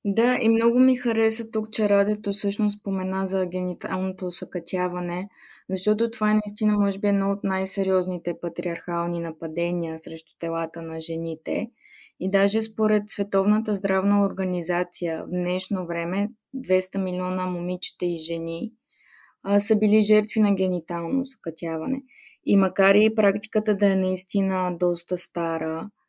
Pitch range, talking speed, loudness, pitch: 175-210 Hz, 135 wpm, -24 LUFS, 190 Hz